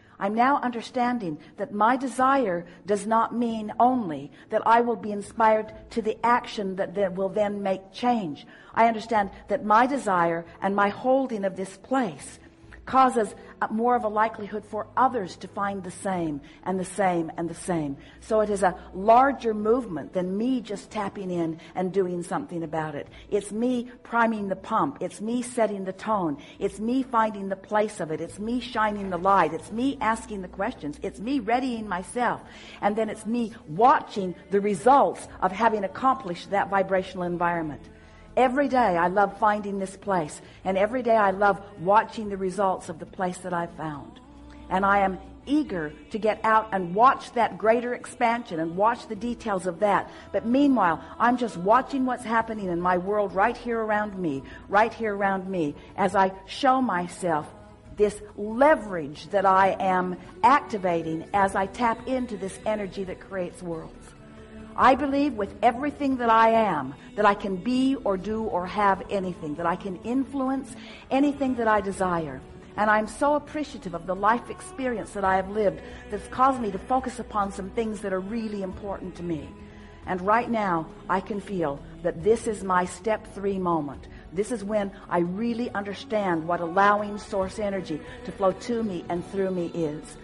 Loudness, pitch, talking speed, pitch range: -26 LUFS, 205 Hz, 180 wpm, 185-230 Hz